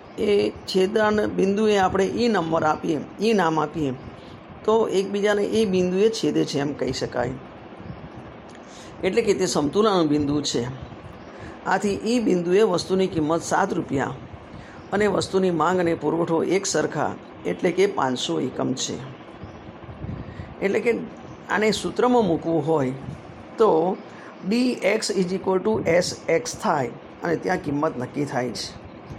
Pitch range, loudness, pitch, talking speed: 150-210 Hz, -23 LUFS, 185 Hz, 135 wpm